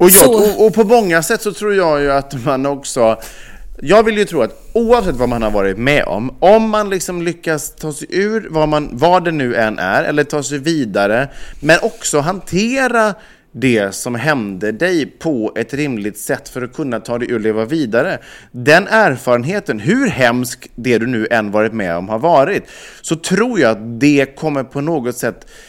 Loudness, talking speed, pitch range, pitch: -15 LUFS, 200 wpm, 120-190 Hz, 145 Hz